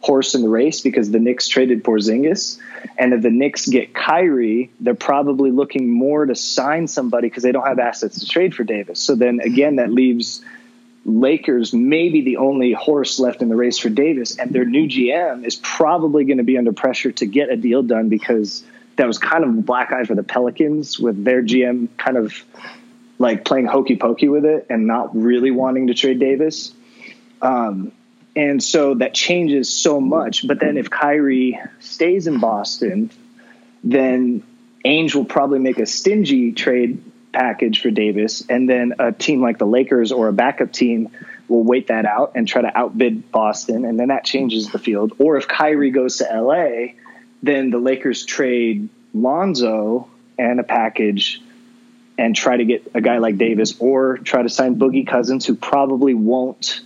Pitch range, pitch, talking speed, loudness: 120-160 Hz, 130 Hz, 185 wpm, -17 LUFS